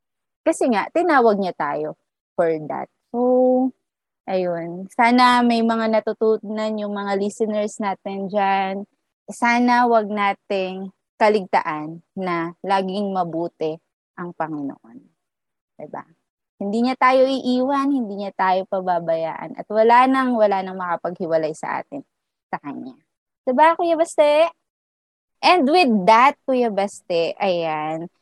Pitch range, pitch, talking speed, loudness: 180-245 Hz, 205 Hz, 115 wpm, -20 LUFS